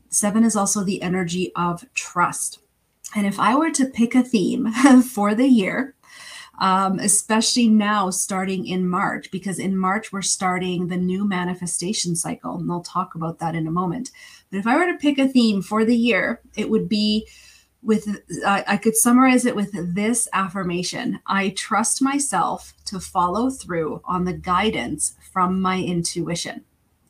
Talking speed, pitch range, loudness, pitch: 170 wpm, 180-230 Hz, -21 LUFS, 200 Hz